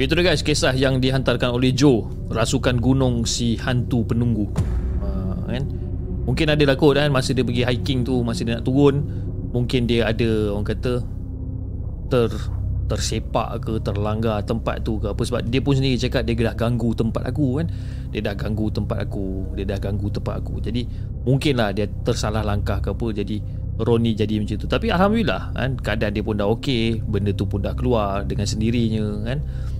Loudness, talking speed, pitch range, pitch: -22 LUFS, 185 wpm, 100-125 Hz, 115 Hz